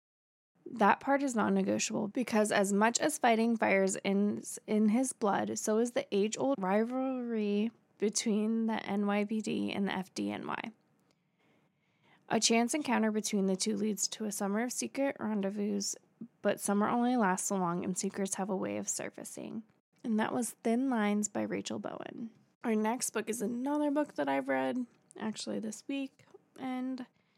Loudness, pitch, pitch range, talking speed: -32 LUFS, 215 Hz, 200-240 Hz, 160 wpm